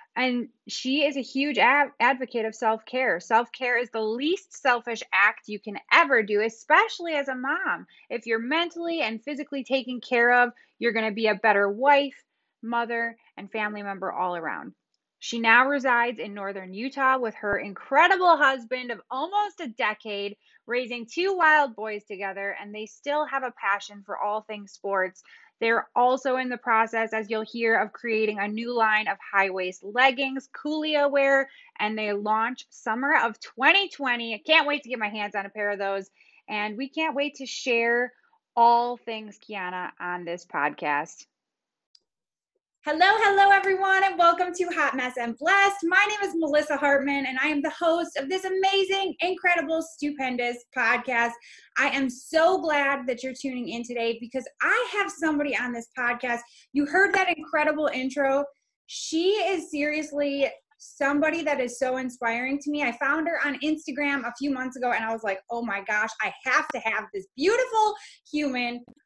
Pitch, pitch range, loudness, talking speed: 255 Hz, 225-300 Hz, -25 LUFS, 175 wpm